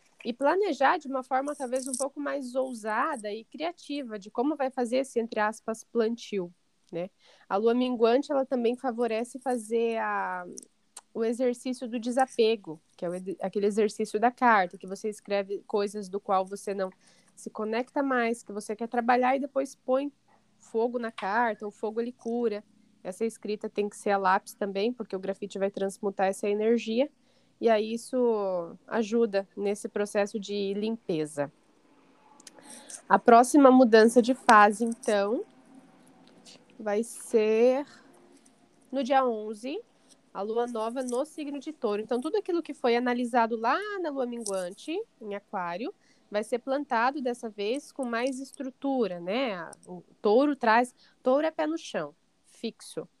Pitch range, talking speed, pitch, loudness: 210-260 Hz, 155 wpm, 230 Hz, -28 LUFS